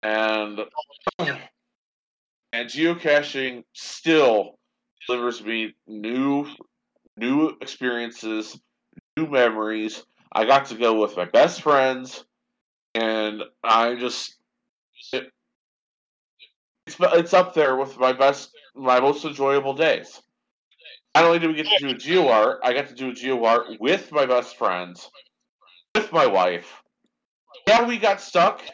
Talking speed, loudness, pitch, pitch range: 125 wpm, -22 LUFS, 125 Hz, 110-140 Hz